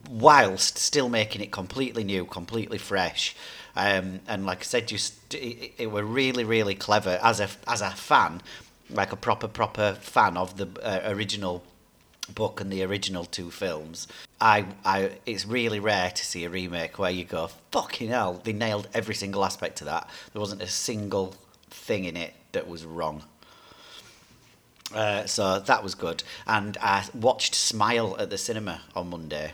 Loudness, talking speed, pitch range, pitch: -27 LUFS, 175 wpm, 90-110 Hz, 100 Hz